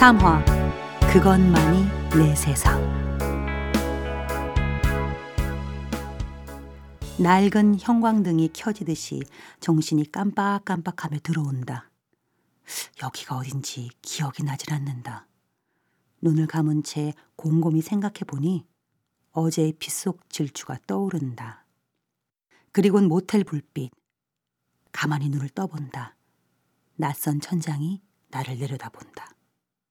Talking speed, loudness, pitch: 195 characters per minute, -24 LUFS, 140 Hz